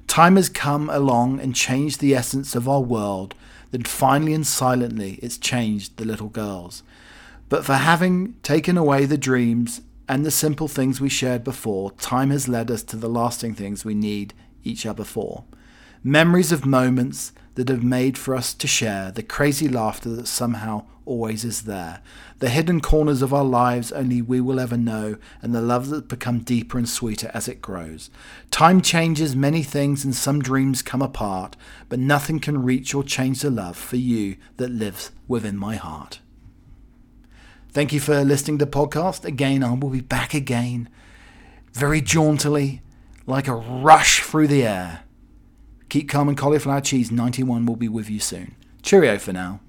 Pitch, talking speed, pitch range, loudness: 125 Hz, 175 wpm, 115-140 Hz, -21 LUFS